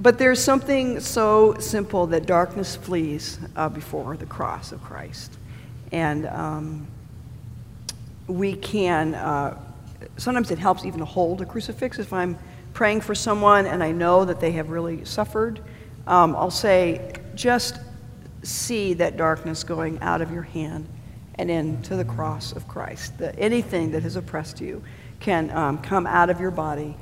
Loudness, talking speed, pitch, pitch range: -23 LUFS, 160 wpm, 170 Hz, 150-195 Hz